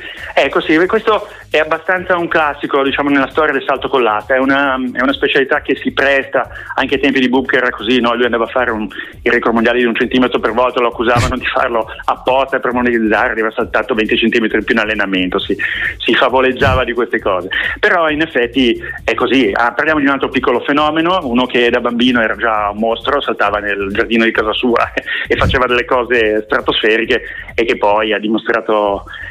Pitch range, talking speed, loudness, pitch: 115-140 Hz, 200 wpm, -14 LUFS, 125 Hz